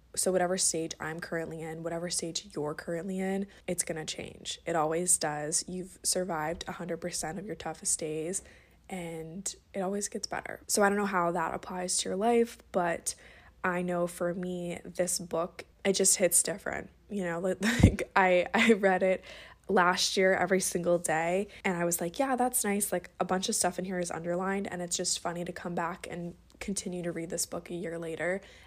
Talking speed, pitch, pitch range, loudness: 195 wpm, 180 Hz, 170-190 Hz, -30 LUFS